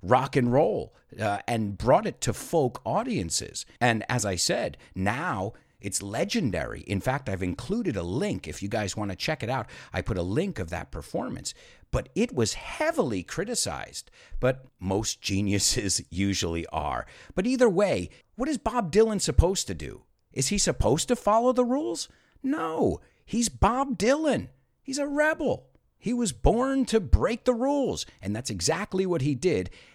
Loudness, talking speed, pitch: -27 LUFS, 170 wpm, 135 Hz